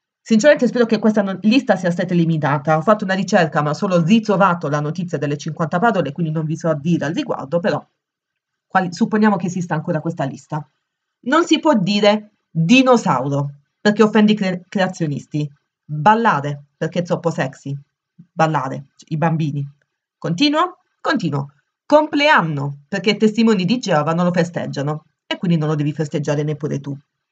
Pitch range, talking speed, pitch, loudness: 150-210 Hz, 165 wpm, 170 Hz, -18 LUFS